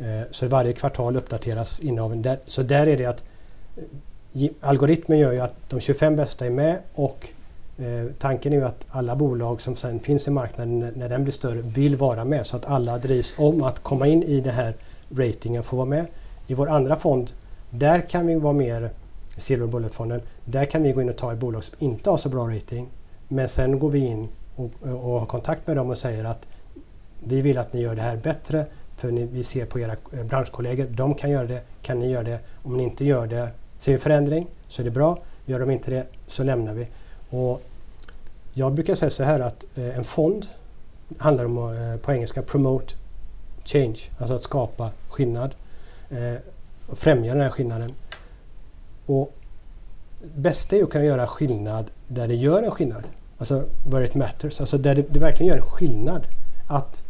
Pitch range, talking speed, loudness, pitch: 115-140 Hz, 185 wpm, -24 LUFS, 125 Hz